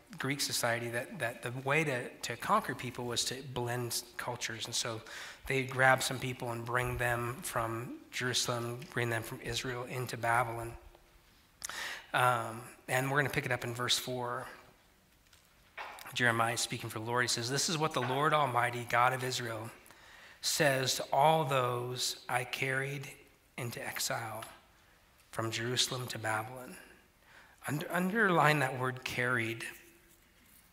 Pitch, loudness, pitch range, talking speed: 125 Hz, -33 LUFS, 120-130 Hz, 150 wpm